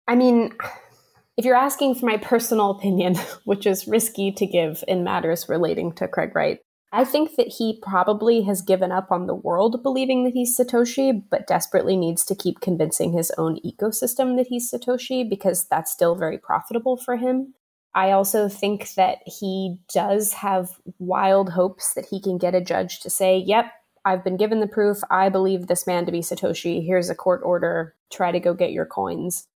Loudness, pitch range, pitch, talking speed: -22 LUFS, 180-235 Hz, 195 Hz, 190 wpm